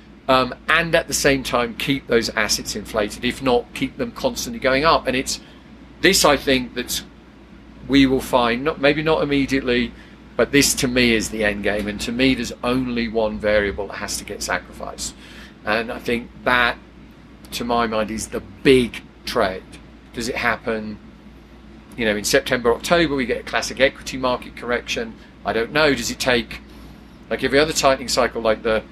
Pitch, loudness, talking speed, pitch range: 130 Hz, -20 LUFS, 180 wpm, 115-140 Hz